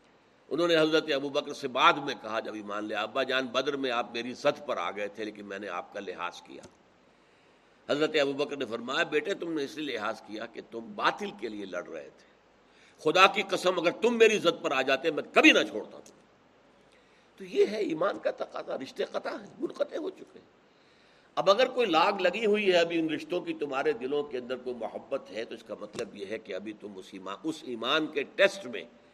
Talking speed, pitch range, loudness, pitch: 225 wpm, 115-175 Hz, -29 LUFS, 145 Hz